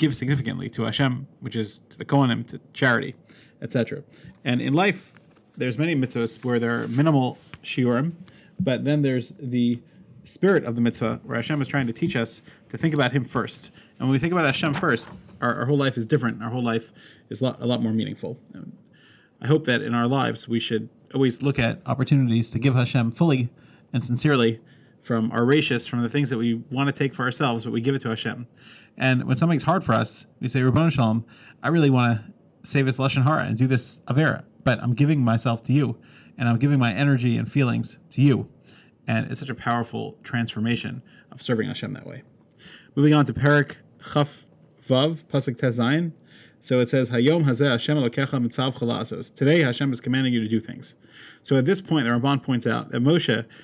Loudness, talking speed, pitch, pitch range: -23 LUFS, 205 wpm, 130 Hz, 120-145 Hz